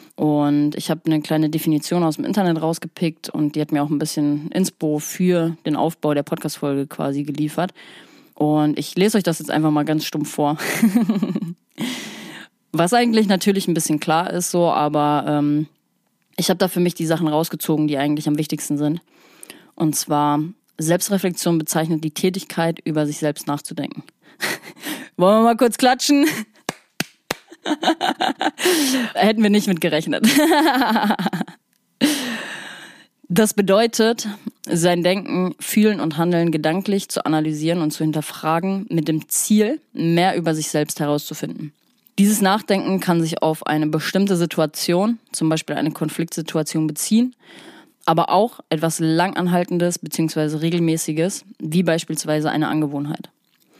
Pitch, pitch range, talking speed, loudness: 170 Hz, 155-205 Hz, 140 wpm, -20 LUFS